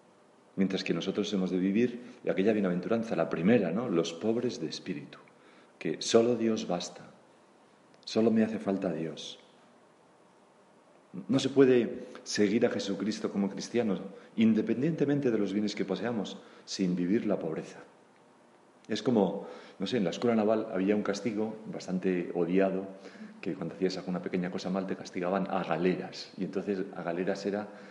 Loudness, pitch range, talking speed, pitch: -31 LUFS, 95-110 Hz, 155 wpm, 100 Hz